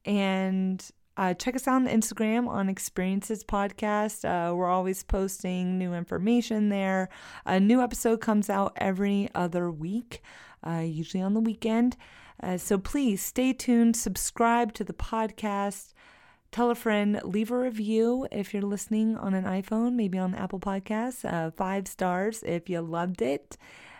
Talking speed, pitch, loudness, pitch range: 155 wpm, 205 Hz, -28 LUFS, 190-225 Hz